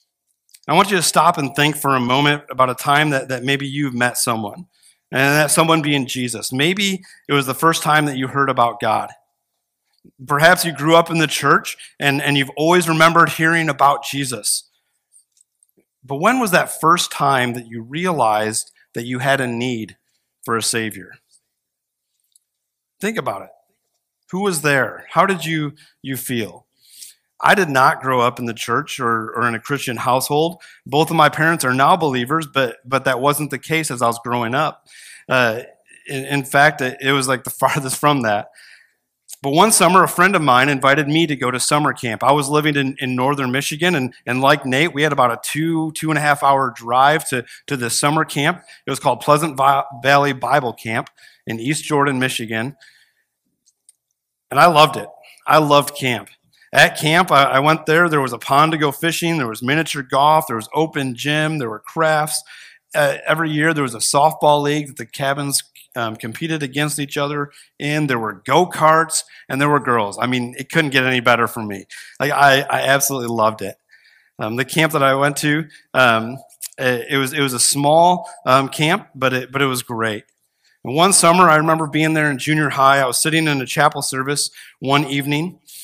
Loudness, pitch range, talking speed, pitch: -17 LUFS, 125-155 Hz, 200 wpm, 140 Hz